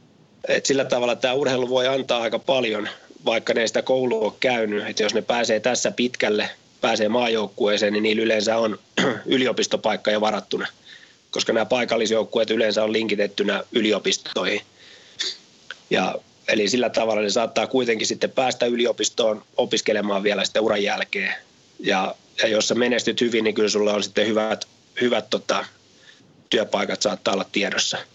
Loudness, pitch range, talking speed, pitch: -22 LUFS, 105-120 Hz, 150 wpm, 110 Hz